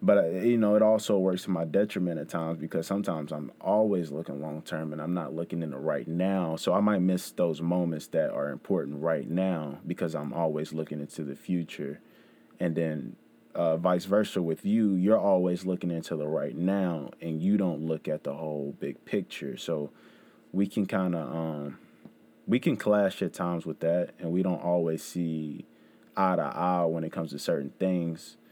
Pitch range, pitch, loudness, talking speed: 80-95 Hz, 85 Hz, -29 LUFS, 200 wpm